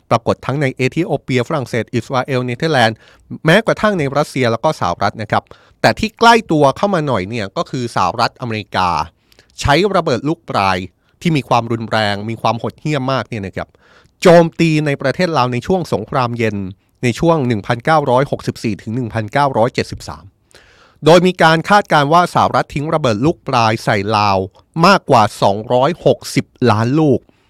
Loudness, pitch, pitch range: -15 LUFS, 125 Hz, 110-155 Hz